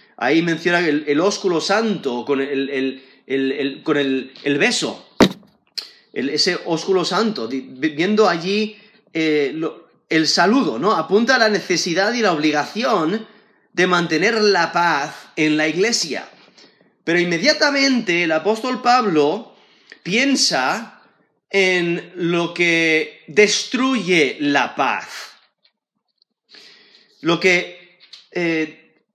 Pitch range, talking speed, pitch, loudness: 155-210 Hz, 115 wpm, 175 Hz, -18 LUFS